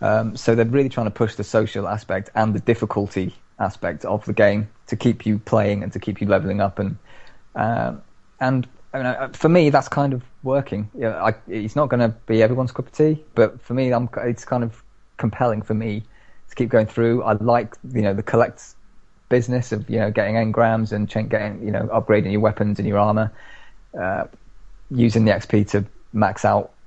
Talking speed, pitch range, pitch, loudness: 210 wpm, 105-120 Hz, 110 Hz, -21 LUFS